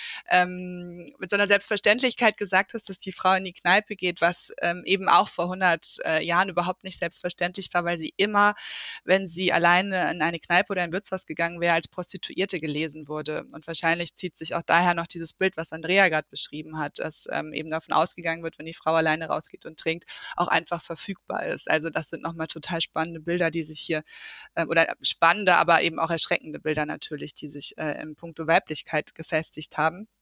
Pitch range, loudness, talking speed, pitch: 160-185 Hz, -25 LUFS, 205 wpm, 170 Hz